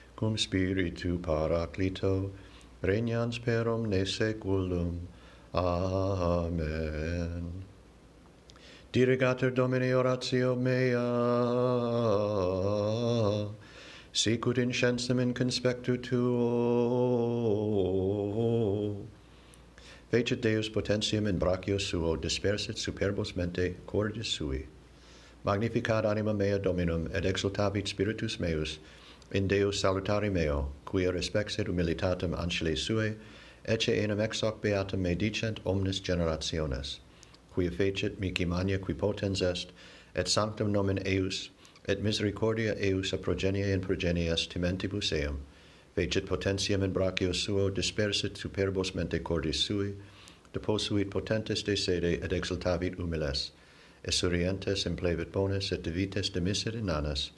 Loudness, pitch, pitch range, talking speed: -31 LUFS, 95 Hz, 90-110 Hz, 105 wpm